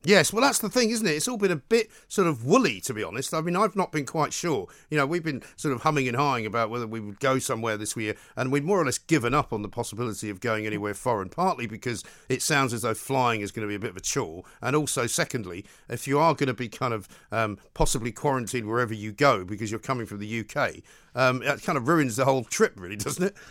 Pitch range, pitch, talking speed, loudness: 110-155 Hz, 130 Hz, 270 wpm, -26 LUFS